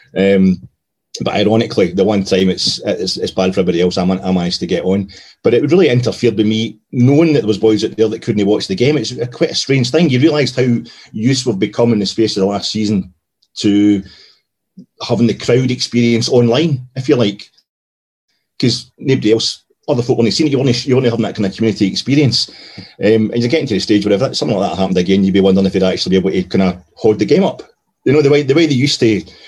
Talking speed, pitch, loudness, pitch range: 250 wpm, 110 Hz, -14 LUFS, 95-125 Hz